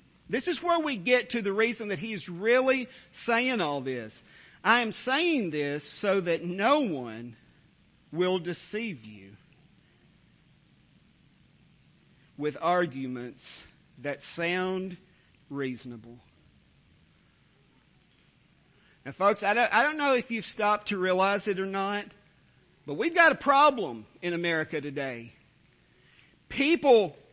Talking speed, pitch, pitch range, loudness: 120 wpm, 185 Hz, 145-225 Hz, -27 LUFS